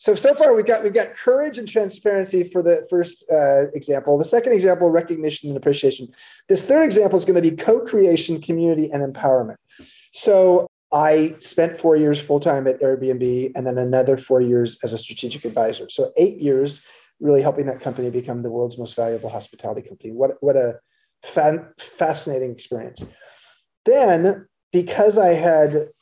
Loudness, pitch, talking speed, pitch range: -19 LUFS, 155 Hz, 170 wpm, 135-190 Hz